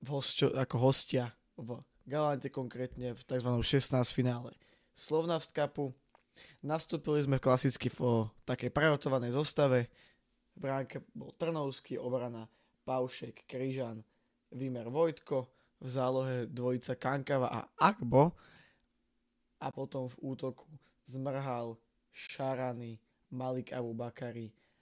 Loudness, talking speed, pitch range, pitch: -34 LUFS, 100 wpm, 125-140 Hz, 130 Hz